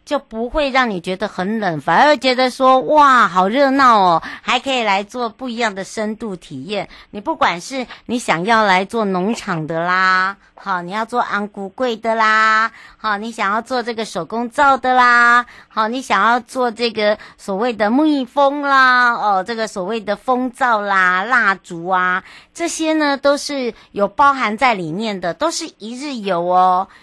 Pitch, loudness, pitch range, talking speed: 225 Hz, -16 LUFS, 195-255 Hz, 240 characters per minute